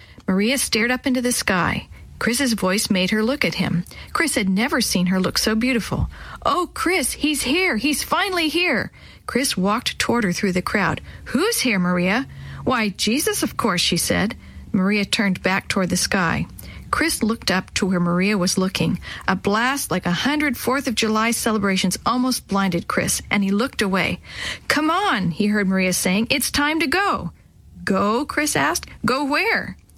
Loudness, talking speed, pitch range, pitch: -20 LUFS, 180 wpm, 190-275 Hz, 225 Hz